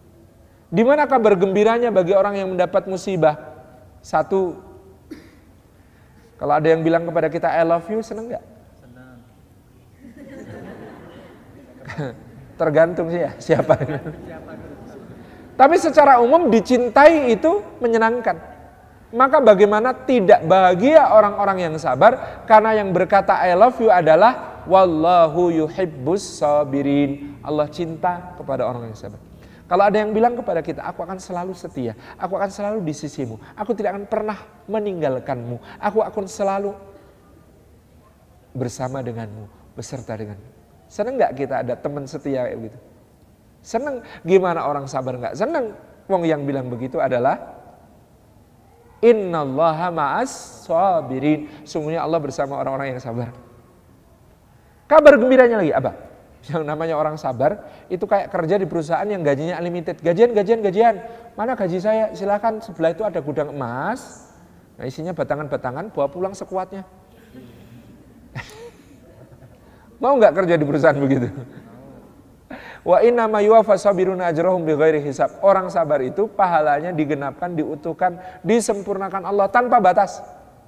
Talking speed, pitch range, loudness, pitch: 125 wpm, 140-210 Hz, -18 LUFS, 175 Hz